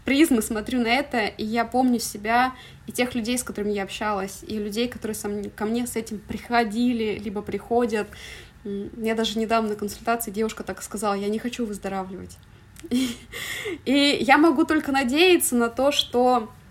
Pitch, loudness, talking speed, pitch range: 230 Hz, -24 LUFS, 170 wpm, 210-245 Hz